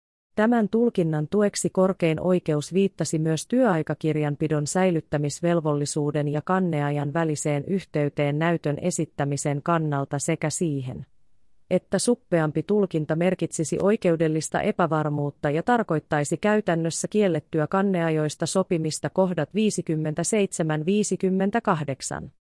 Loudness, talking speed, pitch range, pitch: -24 LUFS, 85 wpm, 150-185 Hz, 165 Hz